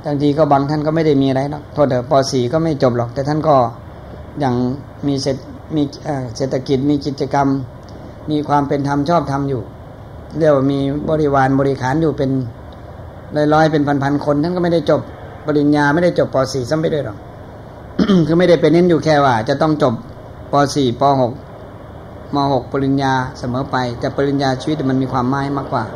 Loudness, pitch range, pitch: -16 LUFS, 125-150 Hz, 140 Hz